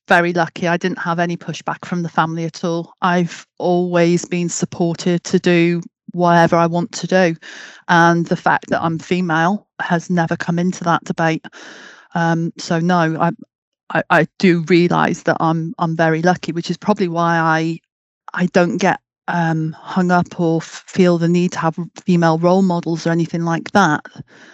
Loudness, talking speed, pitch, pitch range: -17 LUFS, 180 wpm, 170 Hz, 165-180 Hz